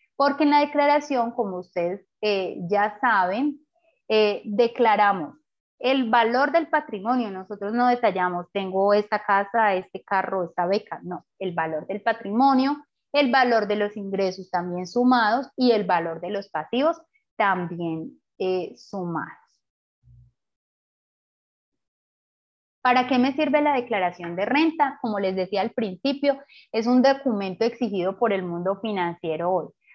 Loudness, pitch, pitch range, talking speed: -23 LUFS, 210 Hz, 185-260 Hz, 135 wpm